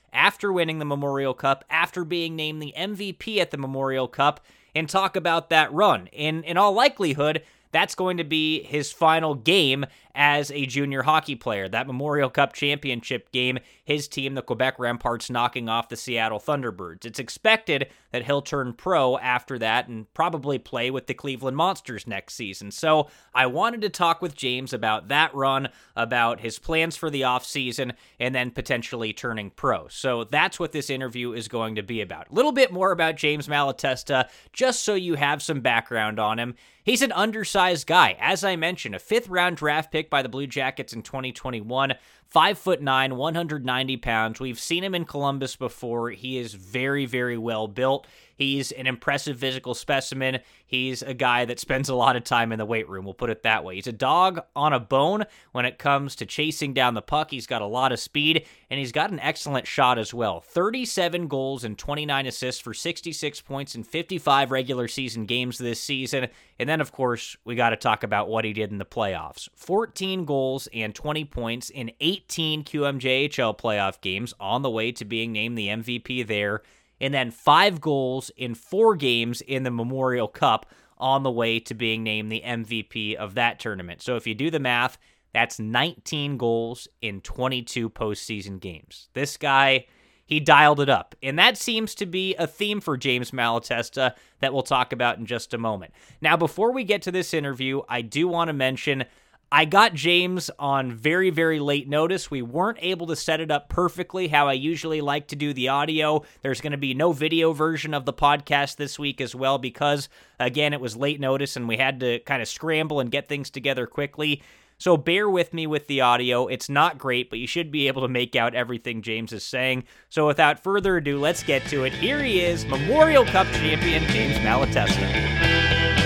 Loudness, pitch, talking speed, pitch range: -24 LUFS, 135 Hz, 195 wpm, 120-155 Hz